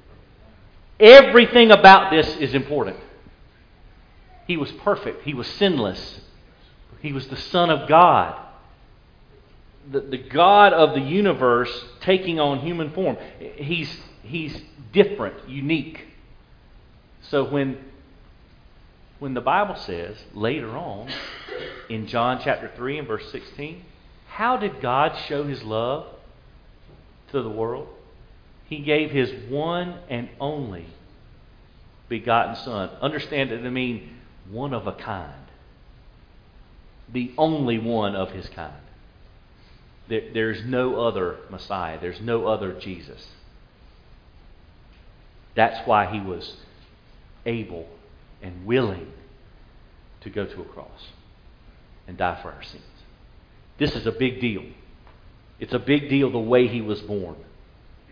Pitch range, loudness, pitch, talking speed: 105-150 Hz, -20 LUFS, 120 Hz, 120 wpm